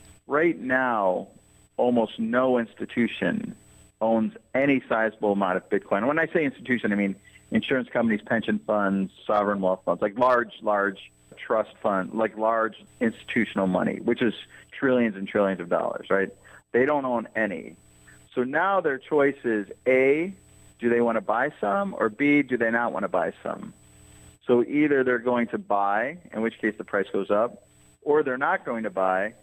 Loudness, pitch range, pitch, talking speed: -25 LUFS, 100-125 Hz, 110 Hz, 175 wpm